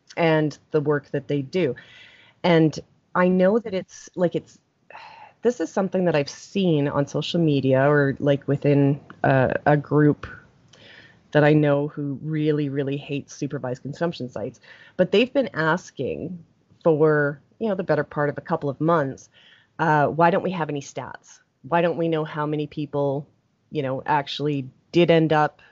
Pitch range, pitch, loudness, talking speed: 140-170 Hz, 150 Hz, -23 LUFS, 170 wpm